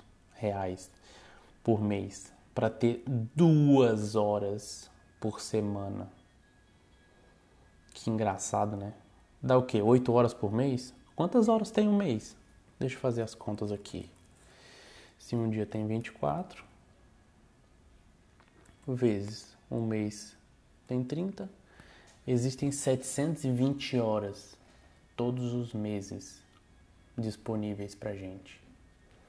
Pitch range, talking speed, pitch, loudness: 95-125 Hz, 100 wpm, 105 Hz, -31 LUFS